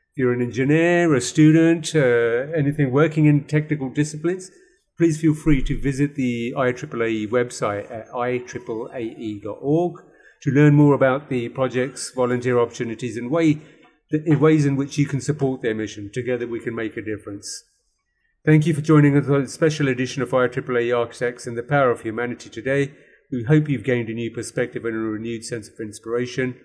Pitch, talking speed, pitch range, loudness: 130 Hz, 175 wpm, 120-150 Hz, -21 LUFS